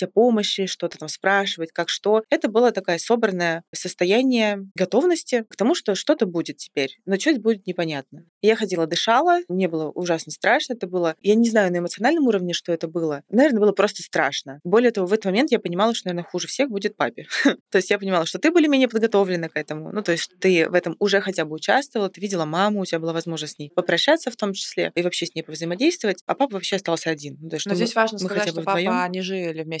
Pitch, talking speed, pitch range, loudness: 185 Hz, 220 wpm, 170-215 Hz, -22 LUFS